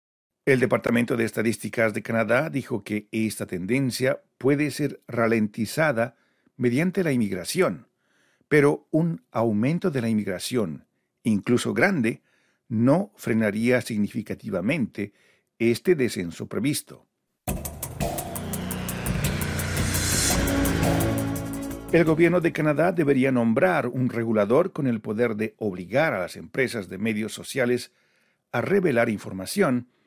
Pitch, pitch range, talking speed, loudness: 115 Hz, 110-135 Hz, 105 wpm, -24 LUFS